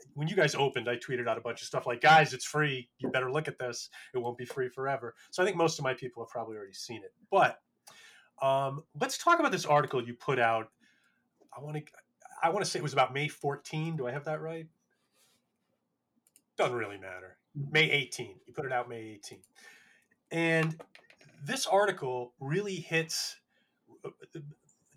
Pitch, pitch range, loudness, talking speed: 145 Hz, 125-160 Hz, -31 LUFS, 195 wpm